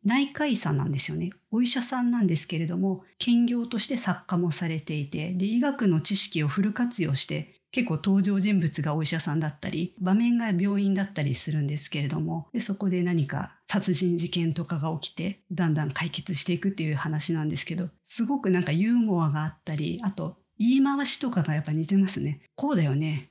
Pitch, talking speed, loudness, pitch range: 175 Hz, 410 characters per minute, -27 LUFS, 160-200 Hz